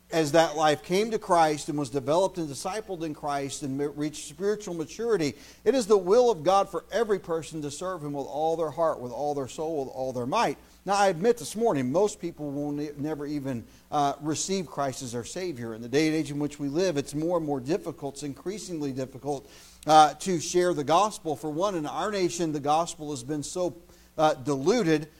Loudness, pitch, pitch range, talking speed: -27 LUFS, 155 Hz, 145-180 Hz, 220 wpm